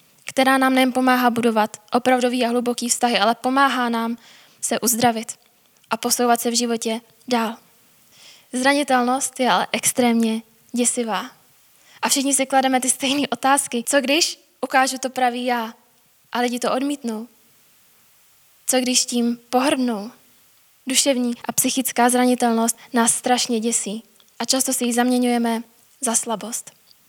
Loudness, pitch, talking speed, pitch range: -20 LUFS, 245 Hz, 135 wpm, 230-260 Hz